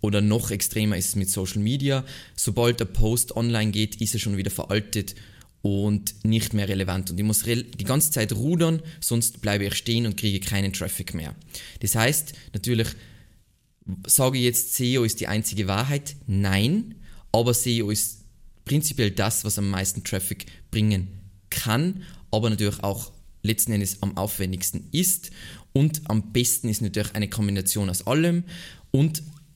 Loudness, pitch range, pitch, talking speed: -24 LUFS, 100-120 Hz, 110 Hz, 160 wpm